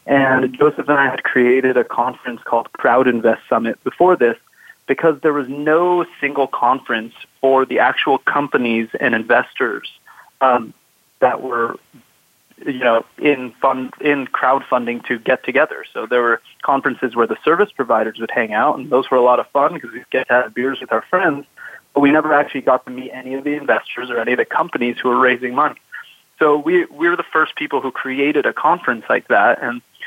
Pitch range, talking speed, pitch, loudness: 125-145 Hz, 200 wpm, 130 Hz, -17 LUFS